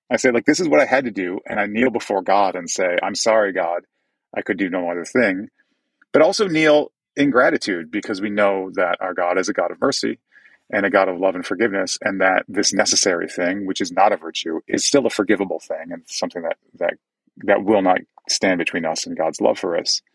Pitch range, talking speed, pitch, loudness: 95-115 Hz, 235 wpm, 100 Hz, -19 LUFS